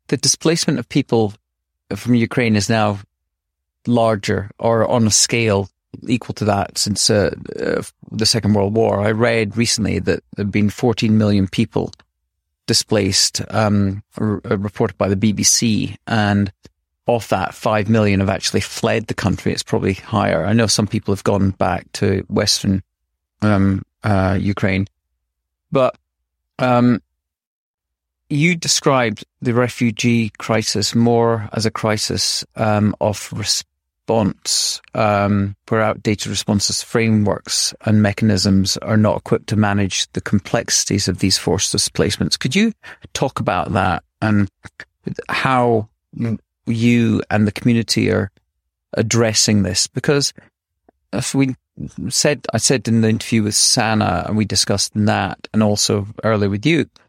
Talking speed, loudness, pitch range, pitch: 140 wpm, -17 LUFS, 100-115 Hz, 105 Hz